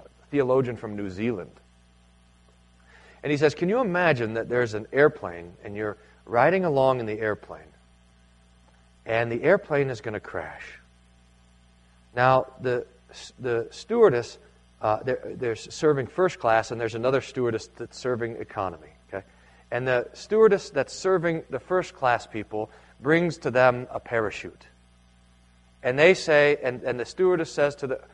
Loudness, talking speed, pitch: -25 LUFS, 150 wpm, 115 Hz